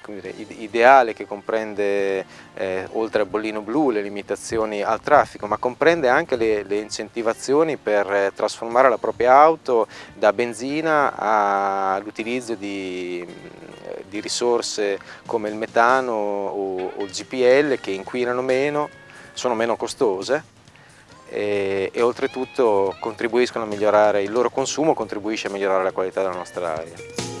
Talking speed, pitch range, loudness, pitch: 135 wpm, 100-125 Hz, -21 LUFS, 110 Hz